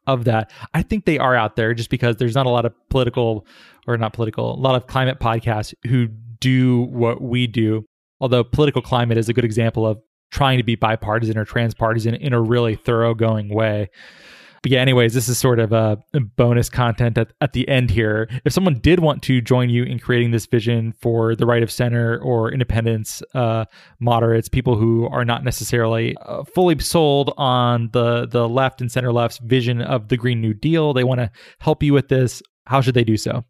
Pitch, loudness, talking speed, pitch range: 120 Hz, -19 LUFS, 210 wpm, 115-130 Hz